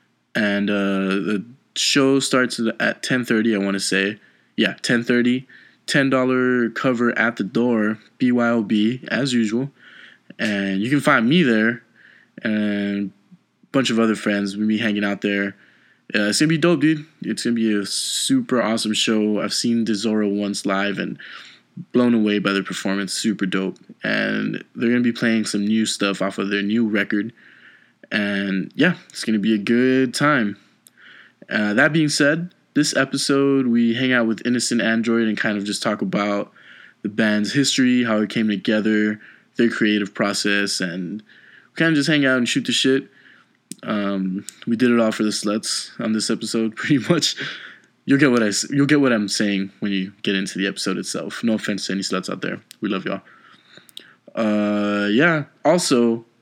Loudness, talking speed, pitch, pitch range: -20 LUFS, 180 wpm, 110 Hz, 100-125 Hz